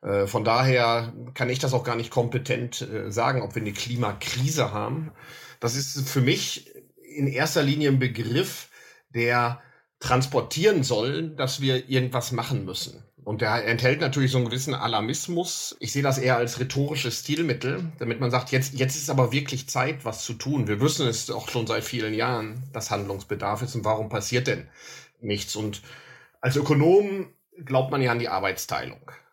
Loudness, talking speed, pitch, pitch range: -25 LUFS, 170 wpm, 125 Hz, 120-135 Hz